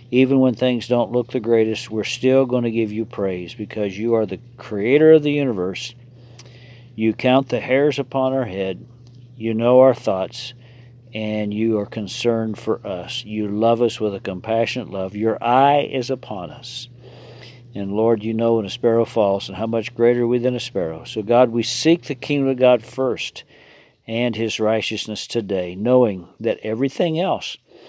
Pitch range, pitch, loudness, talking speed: 110-125 Hz, 120 Hz, -20 LUFS, 180 wpm